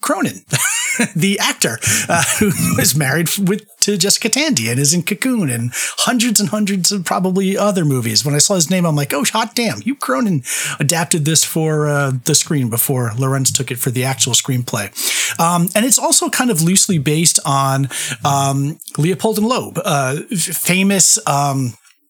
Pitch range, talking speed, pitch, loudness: 140-205 Hz, 180 wpm, 170 Hz, -15 LUFS